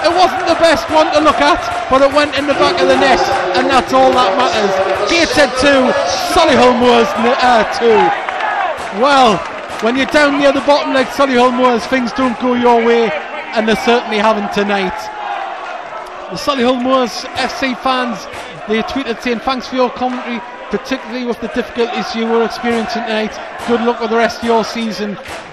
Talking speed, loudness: 185 wpm, -13 LUFS